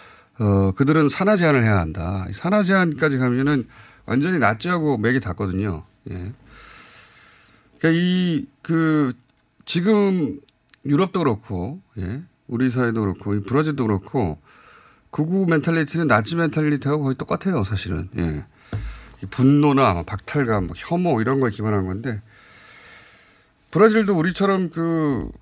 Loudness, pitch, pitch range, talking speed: -21 LUFS, 135 Hz, 105-165 Hz, 285 characters per minute